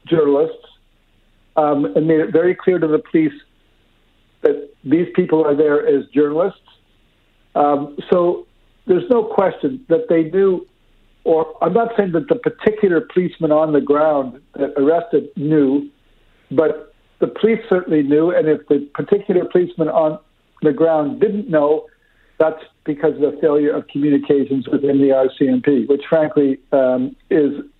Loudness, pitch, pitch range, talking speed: -17 LUFS, 155 Hz, 145-180 Hz, 145 wpm